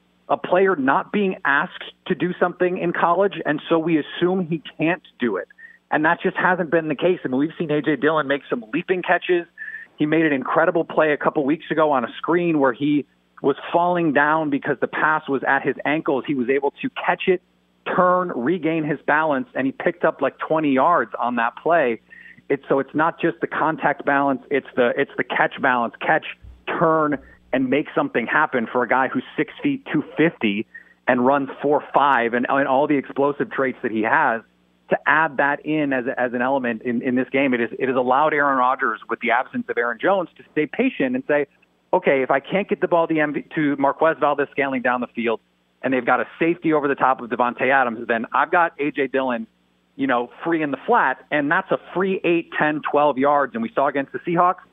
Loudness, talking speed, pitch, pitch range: -21 LUFS, 225 wpm, 150 Hz, 135-175 Hz